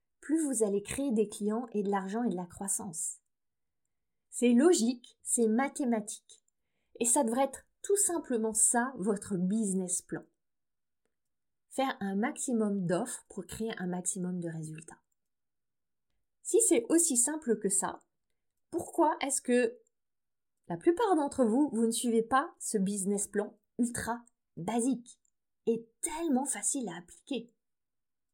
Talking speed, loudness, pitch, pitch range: 135 wpm, -31 LUFS, 235 Hz, 205-270 Hz